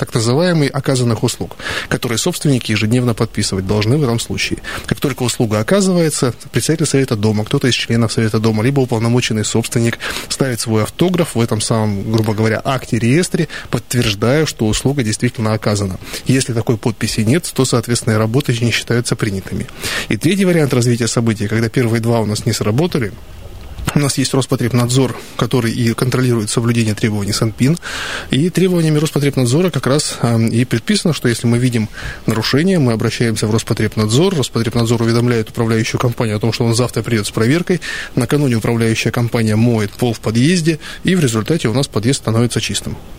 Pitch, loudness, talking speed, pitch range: 120 Hz, -16 LUFS, 160 wpm, 110-135 Hz